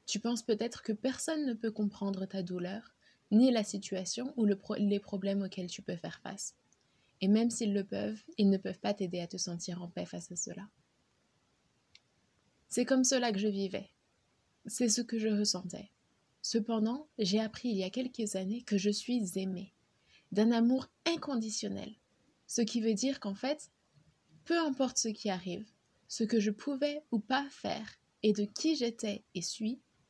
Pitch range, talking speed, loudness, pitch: 195-240 Hz, 180 wpm, -34 LUFS, 215 Hz